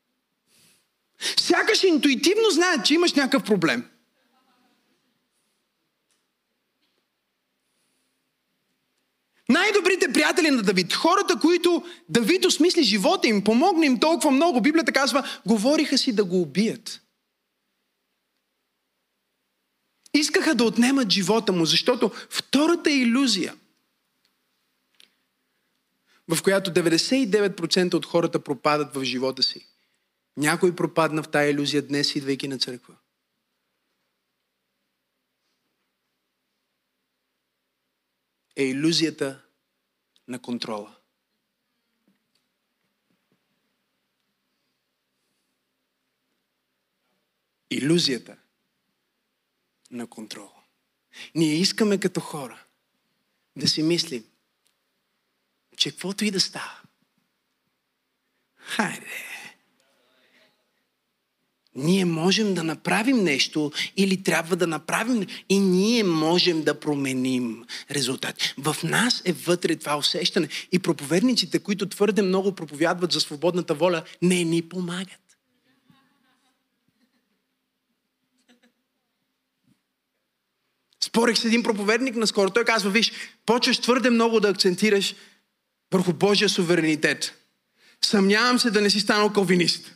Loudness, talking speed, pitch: -22 LUFS, 85 wpm, 185 Hz